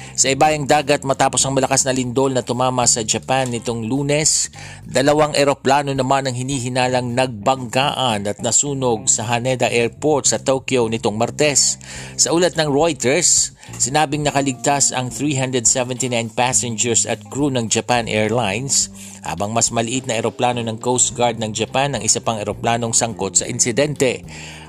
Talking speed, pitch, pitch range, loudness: 145 wpm, 125 Hz, 115-135 Hz, -17 LUFS